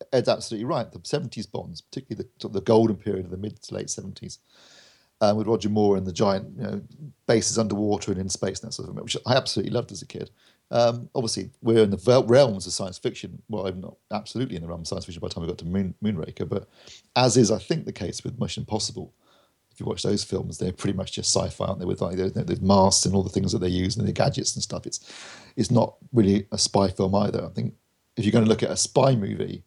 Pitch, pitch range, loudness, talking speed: 105 Hz, 95-115 Hz, -25 LUFS, 265 wpm